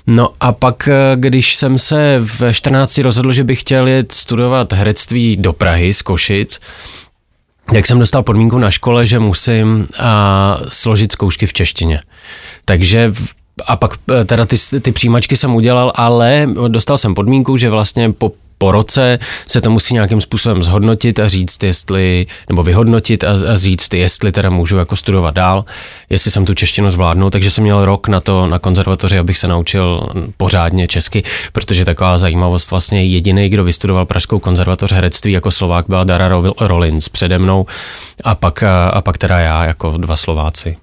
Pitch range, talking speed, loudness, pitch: 90-115 Hz, 170 wpm, -11 LUFS, 100 Hz